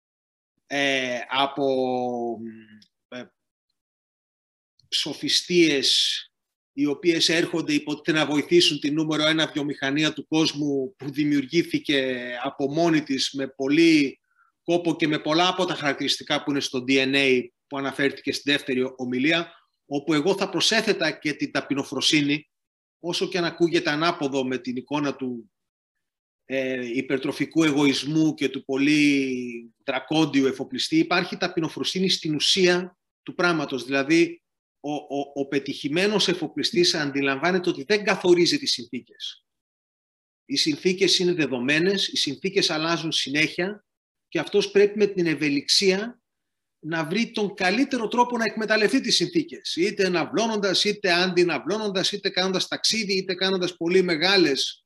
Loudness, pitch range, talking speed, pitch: -23 LUFS, 140-190 Hz, 125 wpm, 160 Hz